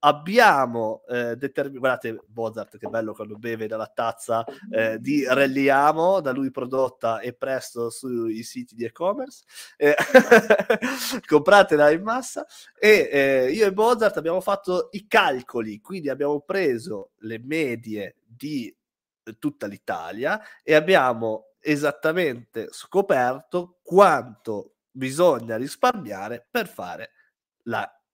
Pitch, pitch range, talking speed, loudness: 140 Hz, 115-195 Hz, 115 wpm, -22 LUFS